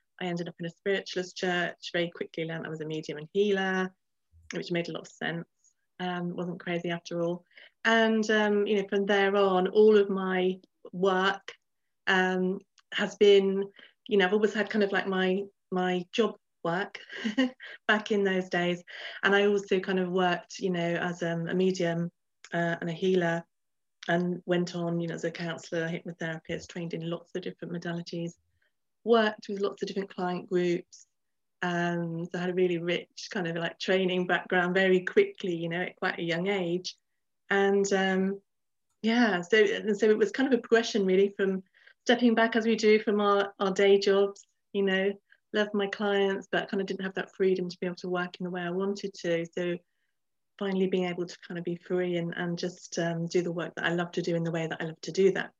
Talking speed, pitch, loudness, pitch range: 210 wpm, 185 Hz, -29 LUFS, 175-200 Hz